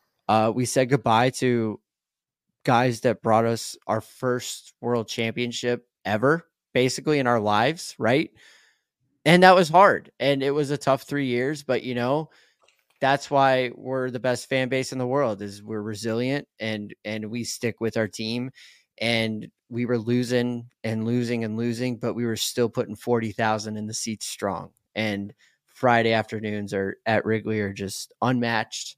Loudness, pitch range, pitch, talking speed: -24 LUFS, 110-130 Hz, 120 Hz, 165 wpm